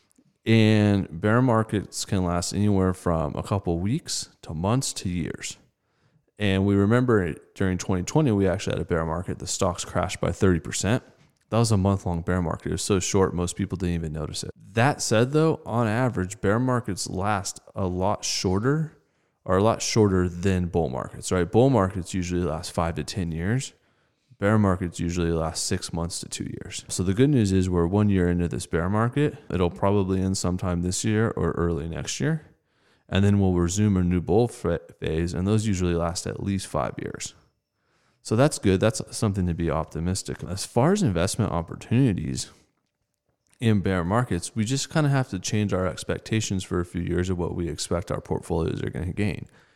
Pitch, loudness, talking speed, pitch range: 95 Hz, -25 LUFS, 195 wpm, 85-110 Hz